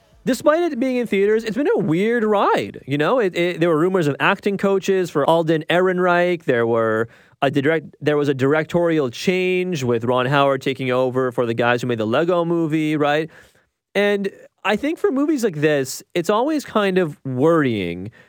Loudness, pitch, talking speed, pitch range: -19 LUFS, 165 Hz, 190 wpm, 140-195 Hz